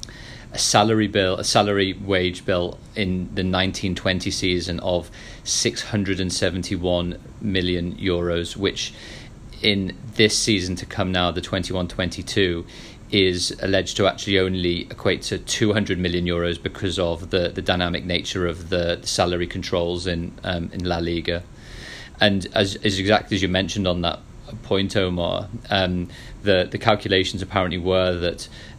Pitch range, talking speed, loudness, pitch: 90-100 Hz, 155 wpm, -22 LUFS, 95 Hz